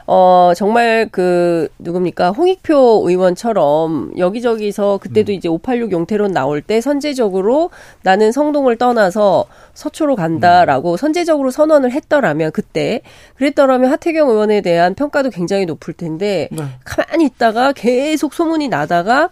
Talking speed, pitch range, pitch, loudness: 315 characters per minute, 180-290 Hz, 220 Hz, -14 LUFS